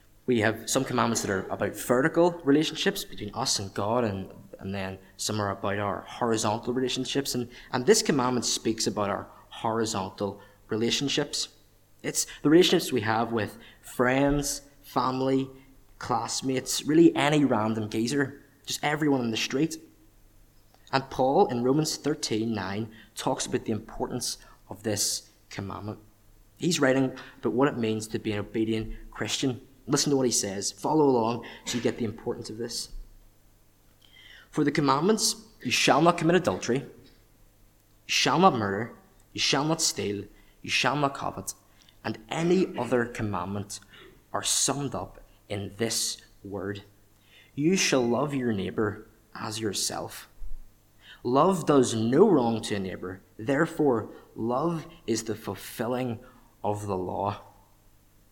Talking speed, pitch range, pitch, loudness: 145 wpm, 105-135 Hz, 115 Hz, -27 LUFS